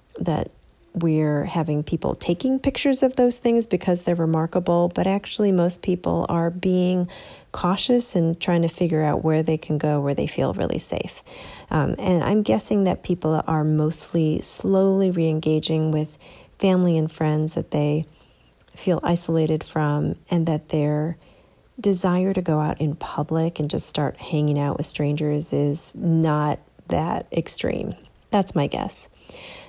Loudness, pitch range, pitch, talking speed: -22 LUFS, 155-185 Hz, 165 Hz, 155 wpm